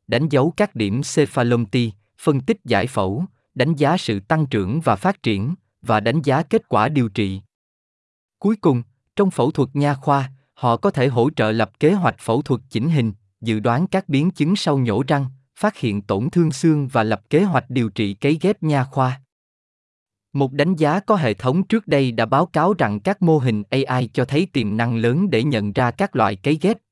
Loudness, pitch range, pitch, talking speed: -20 LUFS, 115-160 Hz, 135 Hz, 210 wpm